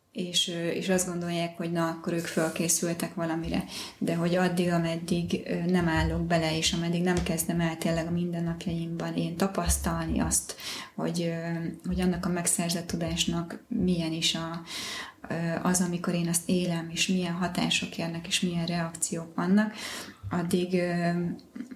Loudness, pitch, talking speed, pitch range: -29 LUFS, 170 Hz, 140 wpm, 165-180 Hz